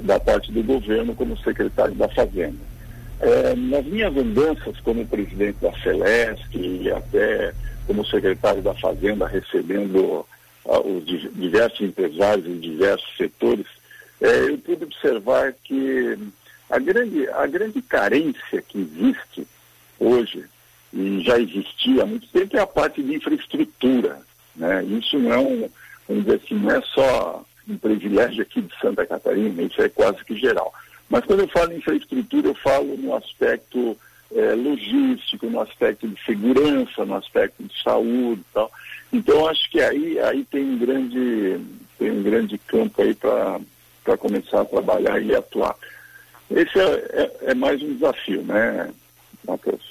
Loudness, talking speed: -21 LUFS, 150 wpm